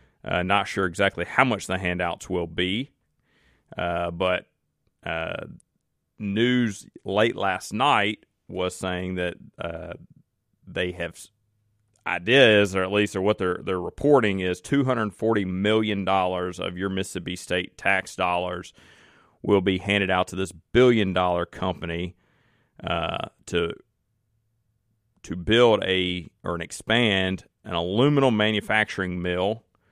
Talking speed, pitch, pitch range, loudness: 125 wpm, 95 Hz, 90-110 Hz, -24 LUFS